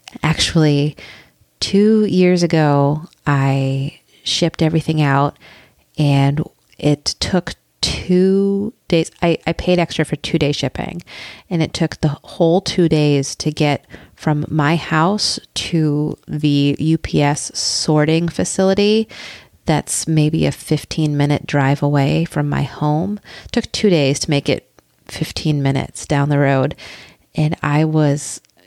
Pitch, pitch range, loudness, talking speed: 155 Hz, 145-170 Hz, -17 LUFS, 130 wpm